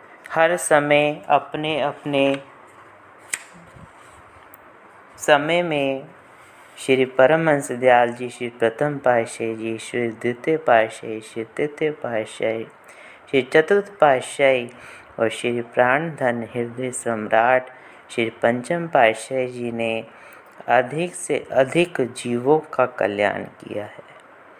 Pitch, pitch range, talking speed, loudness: 130 Hz, 115-150 Hz, 100 wpm, -21 LUFS